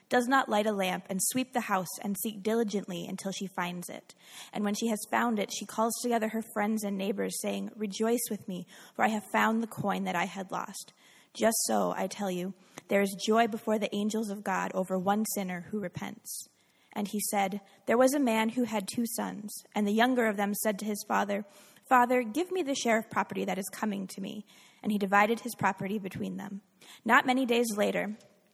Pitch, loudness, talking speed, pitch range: 210 Hz, -30 LUFS, 220 wpm, 195-225 Hz